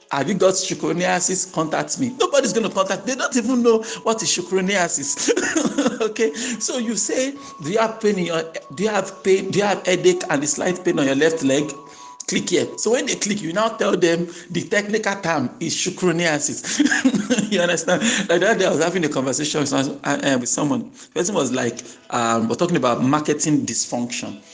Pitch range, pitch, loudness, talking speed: 160-225 Hz, 185 Hz, -20 LUFS, 195 wpm